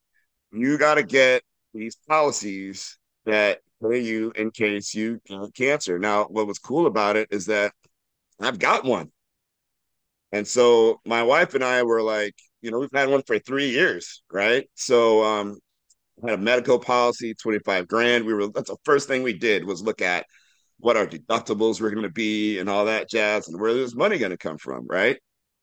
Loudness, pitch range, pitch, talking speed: -22 LUFS, 105-120 Hz, 110 Hz, 185 wpm